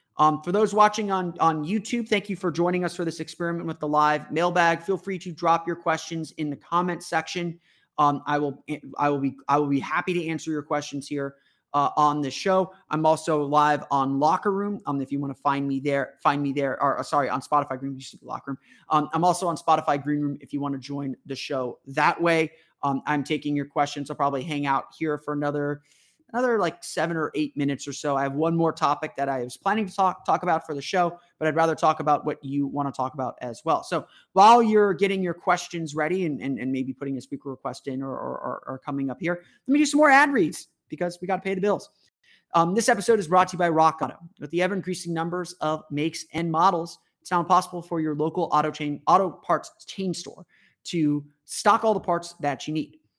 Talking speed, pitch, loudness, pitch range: 240 wpm, 155 Hz, -25 LUFS, 145-175 Hz